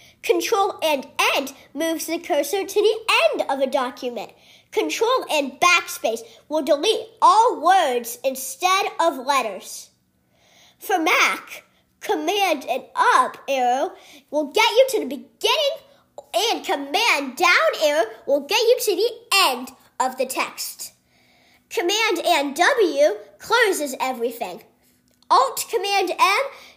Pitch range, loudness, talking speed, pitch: 275-410 Hz, -20 LUFS, 125 wpm, 330 Hz